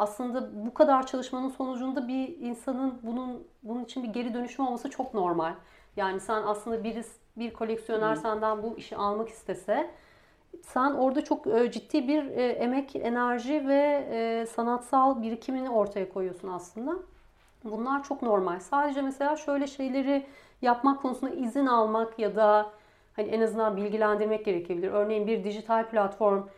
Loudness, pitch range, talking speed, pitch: -29 LUFS, 215-265 Hz, 140 wpm, 235 Hz